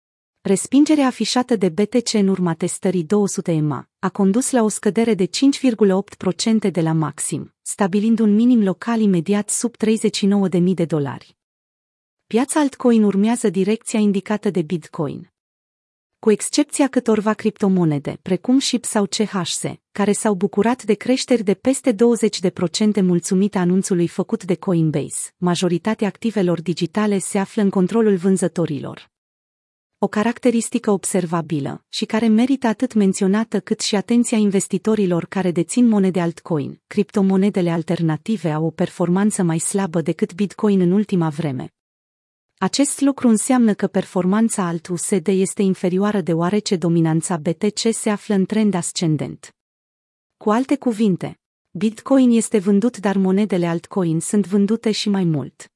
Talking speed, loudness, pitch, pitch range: 130 wpm, -19 LUFS, 200 Hz, 175-220 Hz